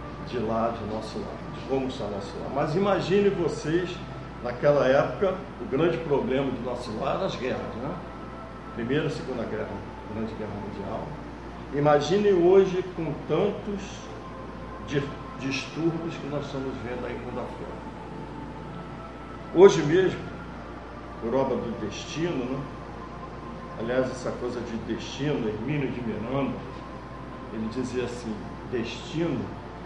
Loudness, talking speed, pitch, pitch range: -27 LUFS, 130 wpm, 130 Hz, 115-155 Hz